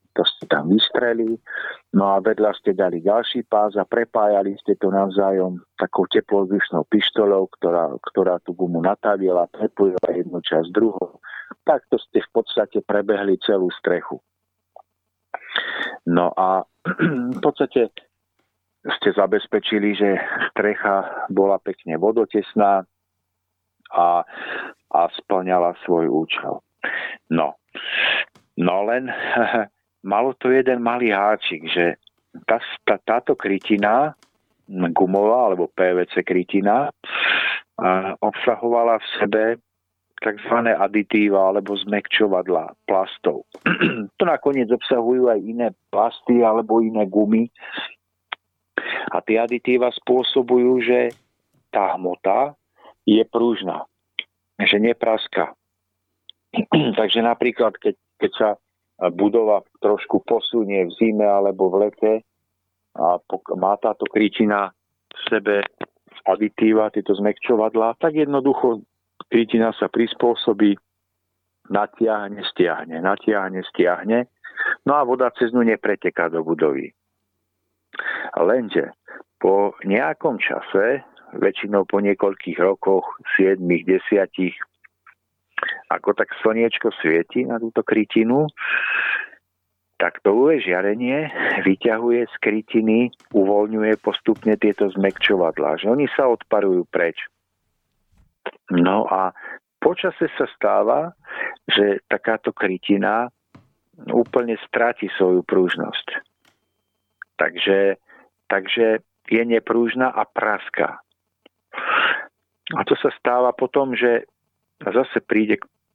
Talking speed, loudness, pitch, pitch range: 100 wpm, -20 LUFS, 105 Hz, 95-115 Hz